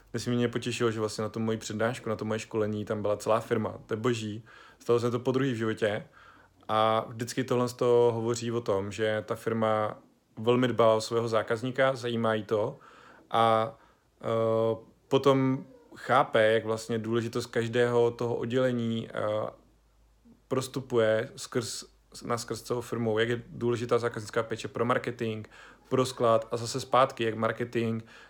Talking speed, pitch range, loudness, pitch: 165 wpm, 110-120 Hz, -29 LUFS, 115 Hz